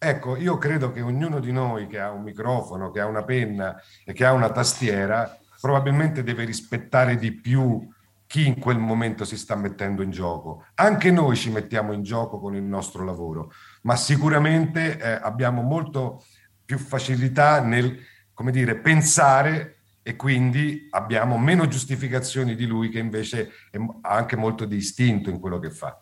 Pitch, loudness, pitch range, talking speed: 120 Hz, -23 LUFS, 105-135 Hz, 165 wpm